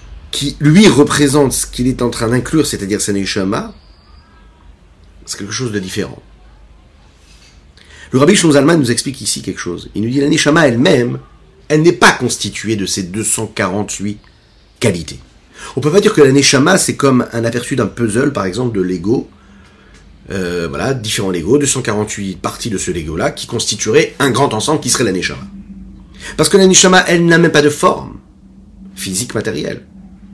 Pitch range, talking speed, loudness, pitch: 95-145 Hz, 175 wpm, -13 LUFS, 110 Hz